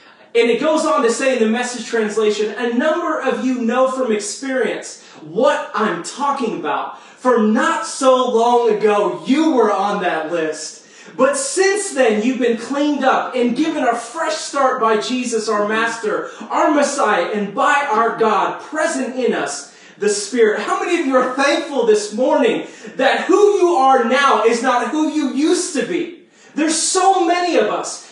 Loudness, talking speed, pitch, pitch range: -17 LUFS, 175 wpm, 255 Hz, 225-305 Hz